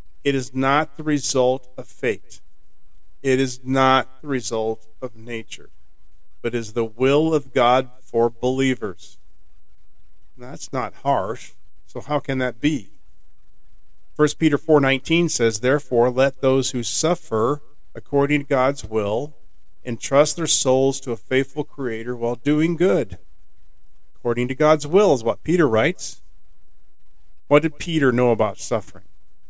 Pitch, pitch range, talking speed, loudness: 125 Hz, 105-140 Hz, 140 wpm, -20 LUFS